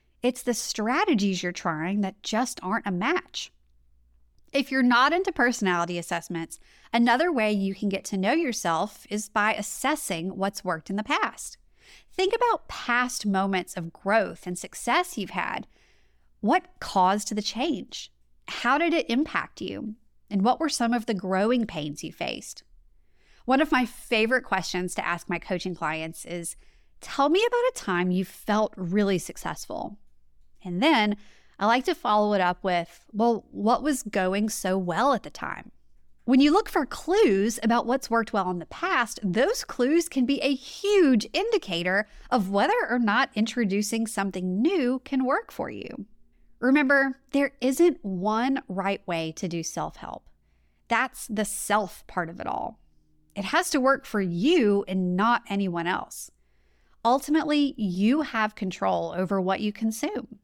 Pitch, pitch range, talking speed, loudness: 210 Hz, 185-260 Hz, 165 wpm, -26 LUFS